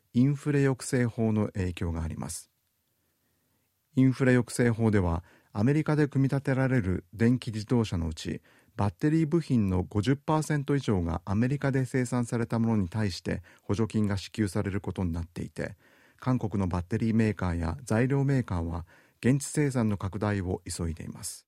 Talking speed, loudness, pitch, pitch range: 340 characters per minute, -29 LUFS, 110 Hz, 95-130 Hz